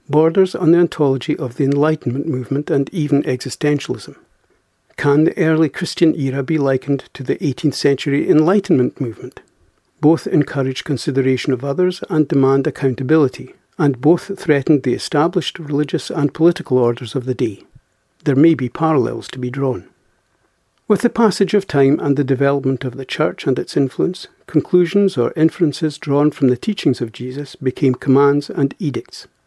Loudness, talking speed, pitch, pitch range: -17 LUFS, 160 wpm, 145 Hz, 135-160 Hz